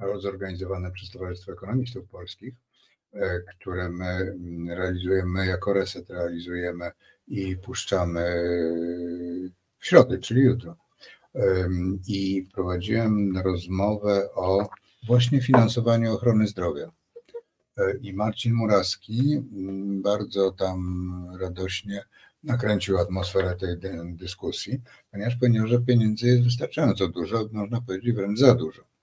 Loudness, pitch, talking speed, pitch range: -25 LUFS, 95 Hz, 95 wpm, 90-115 Hz